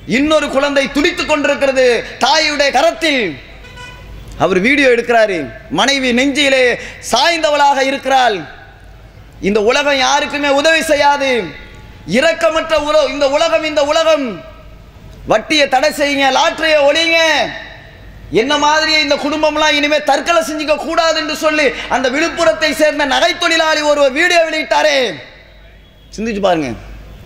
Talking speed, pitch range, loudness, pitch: 105 wpm, 275-320 Hz, -12 LUFS, 295 Hz